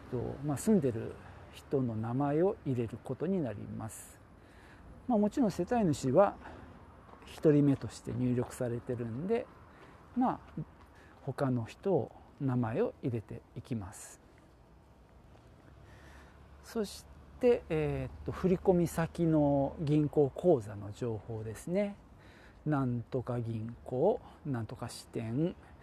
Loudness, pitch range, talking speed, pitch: -33 LUFS, 110-155 Hz, 215 characters per minute, 125 Hz